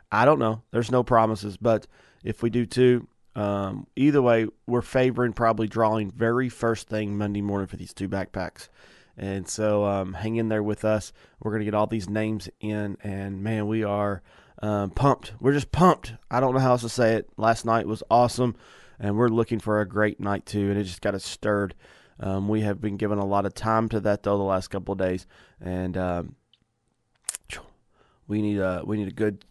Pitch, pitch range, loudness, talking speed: 105 Hz, 100-115 Hz, -25 LUFS, 210 wpm